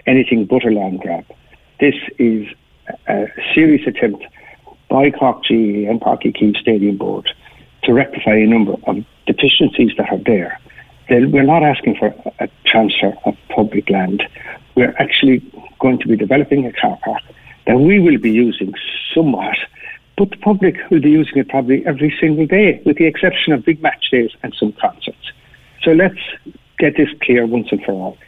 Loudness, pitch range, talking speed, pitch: -14 LUFS, 115-155 Hz, 170 wpm, 130 Hz